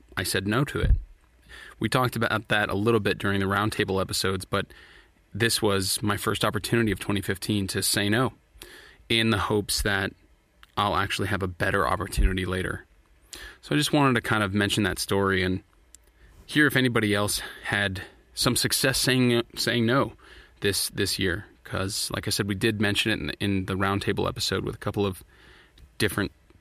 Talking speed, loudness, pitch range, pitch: 180 wpm, -25 LUFS, 95-110 Hz, 100 Hz